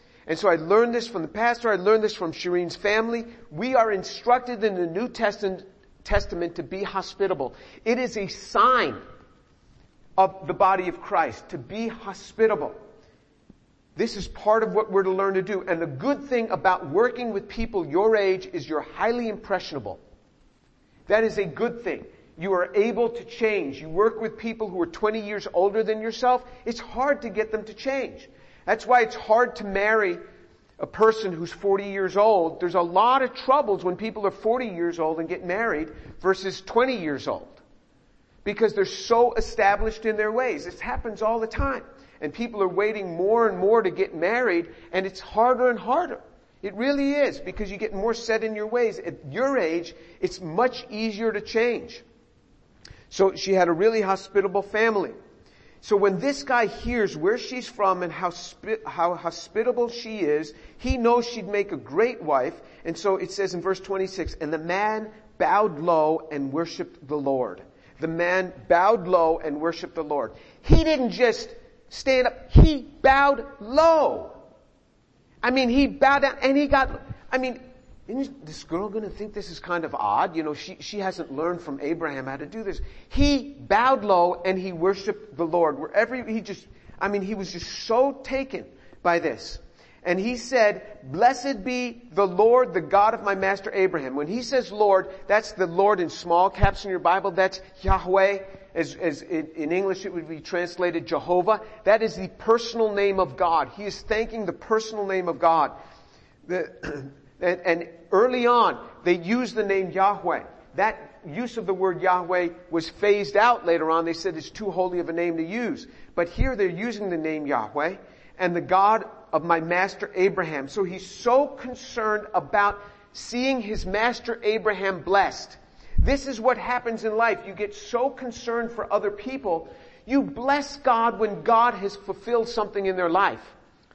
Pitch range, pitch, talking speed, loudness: 180-235 Hz, 205 Hz, 185 wpm, -24 LUFS